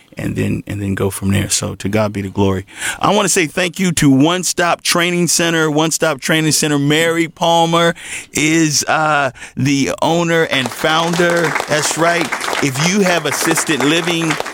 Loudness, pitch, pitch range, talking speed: -14 LUFS, 160 Hz, 135-170 Hz, 180 wpm